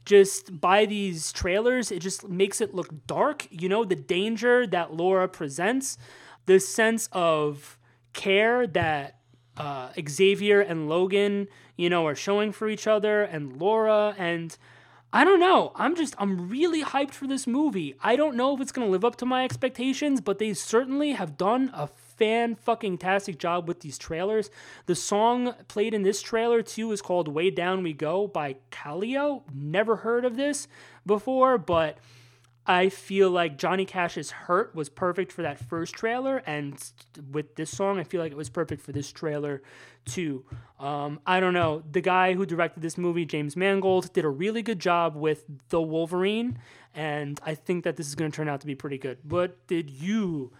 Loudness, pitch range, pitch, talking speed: -26 LUFS, 155-215 Hz, 185 Hz, 185 wpm